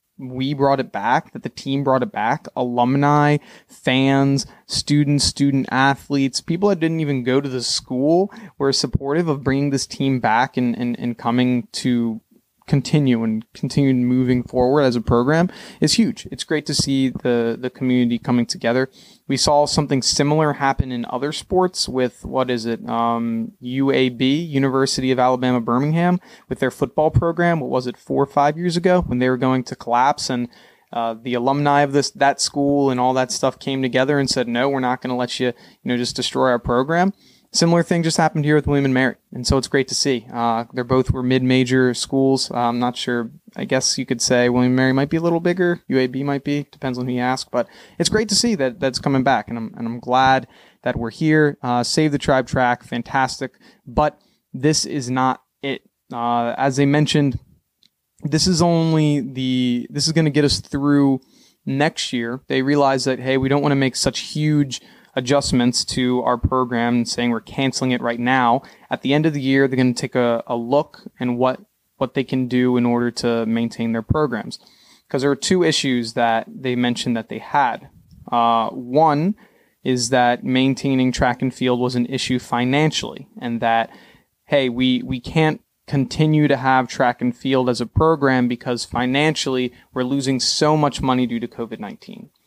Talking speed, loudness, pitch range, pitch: 200 wpm, -19 LUFS, 125-145 Hz, 130 Hz